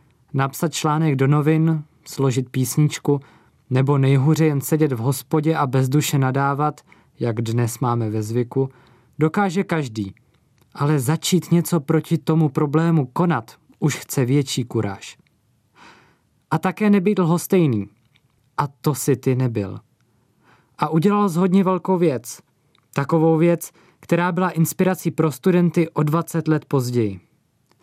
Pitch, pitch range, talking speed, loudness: 150 Hz, 130-165 Hz, 125 wpm, -20 LUFS